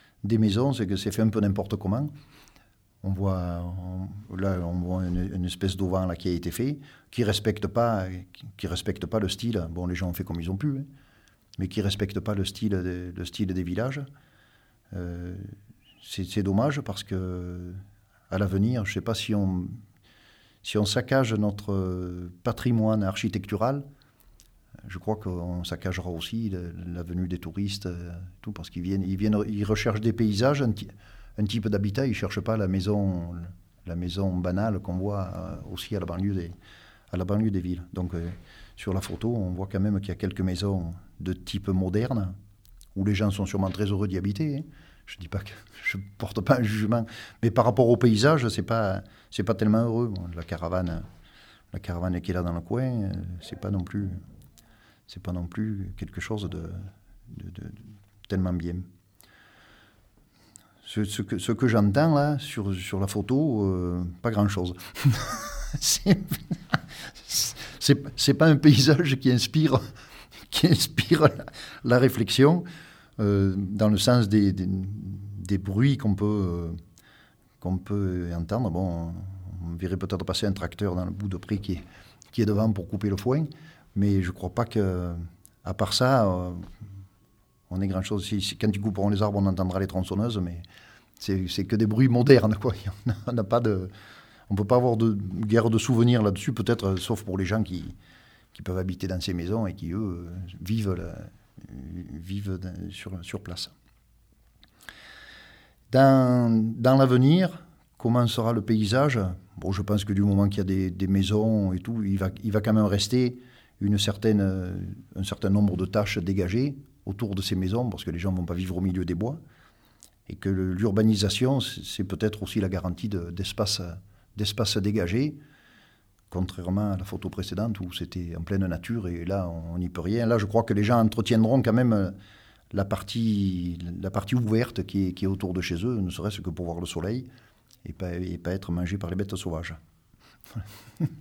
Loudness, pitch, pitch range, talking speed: -27 LUFS, 100 Hz, 95-115 Hz, 185 wpm